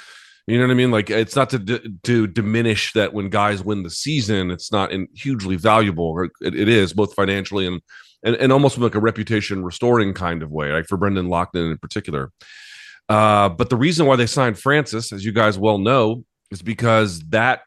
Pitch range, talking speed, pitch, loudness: 95-115 Hz, 210 wpm, 105 Hz, -19 LUFS